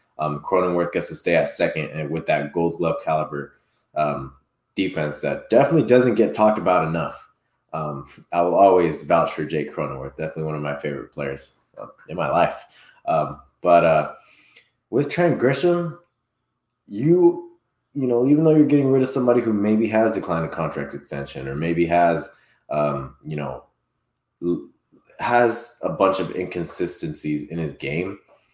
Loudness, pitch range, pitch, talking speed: -21 LUFS, 75-125 Hz, 85 Hz, 160 wpm